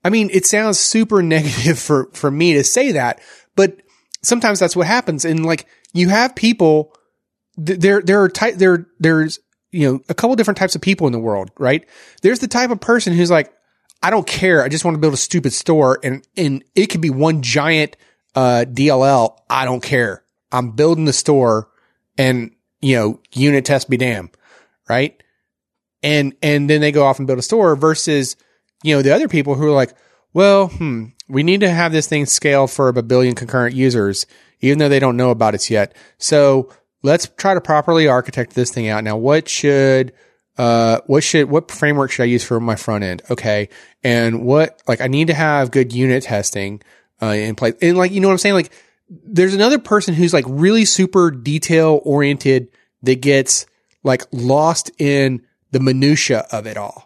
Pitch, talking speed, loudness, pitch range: 145 Hz, 200 wpm, -15 LUFS, 130-175 Hz